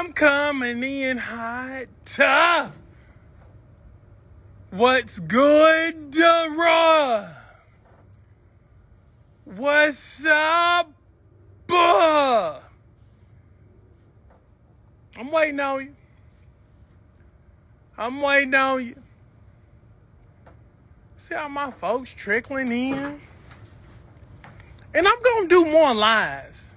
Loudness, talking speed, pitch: -20 LUFS, 70 wpm, 225 Hz